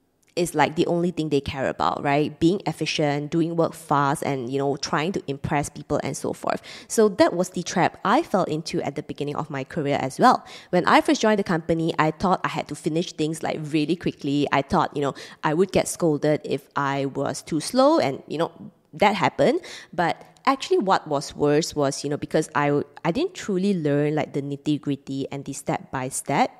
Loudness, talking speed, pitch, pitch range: -24 LUFS, 210 wpm, 150 Hz, 140-175 Hz